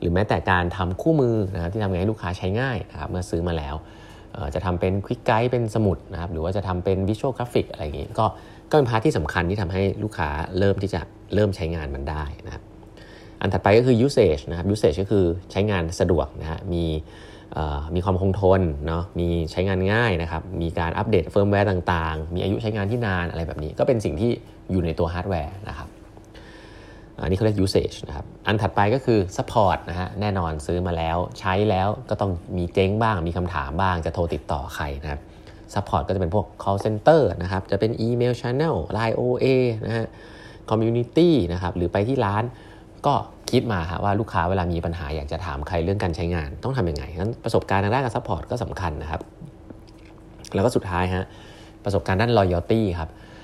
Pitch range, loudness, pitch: 85-110 Hz, -23 LUFS, 95 Hz